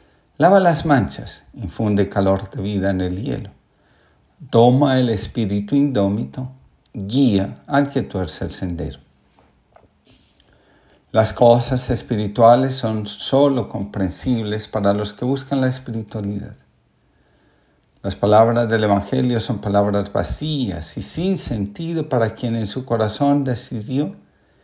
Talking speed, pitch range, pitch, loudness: 115 wpm, 100-130 Hz, 110 Hz, -19 LUFS